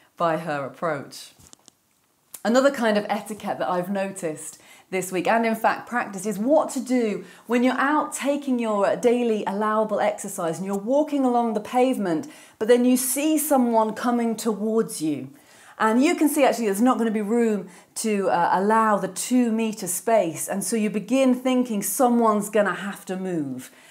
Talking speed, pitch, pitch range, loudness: 180 wpm, 220 Hz, 200-250 Hz, -23 LUFS